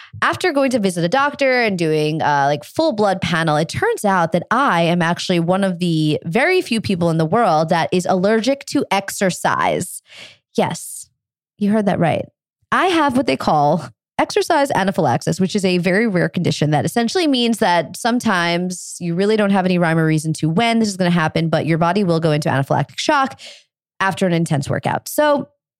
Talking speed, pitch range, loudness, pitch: 200 wpm, 160-230 Hz, -17 LUFS, 185 Hz